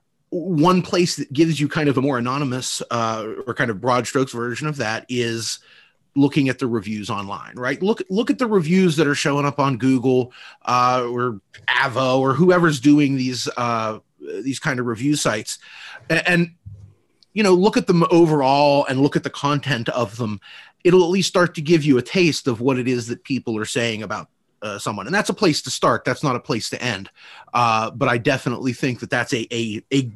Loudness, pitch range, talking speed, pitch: -20 LUFS, 120-155 Hz, 215 wpm, 135 Hz